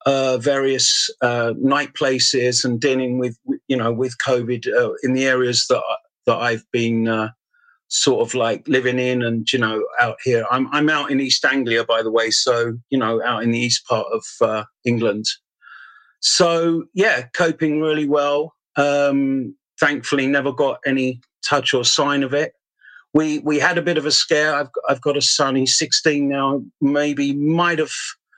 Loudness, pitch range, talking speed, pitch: -18 LUFS, 125-150 Hz, 180 wpm, 135 Hz